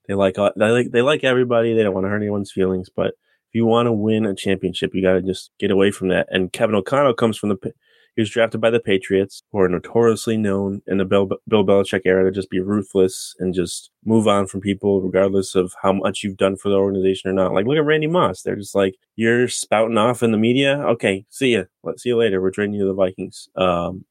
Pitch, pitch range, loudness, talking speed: 100 Hz, 95-115 Hz, -19 LUFS, 250 wpm